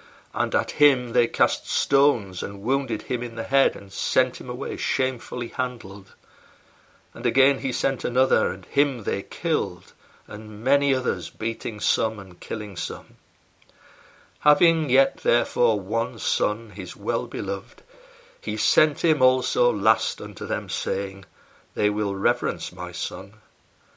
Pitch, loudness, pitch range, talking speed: 135 Hz, -24 LUFS, 120-165 Hz, 140 wpm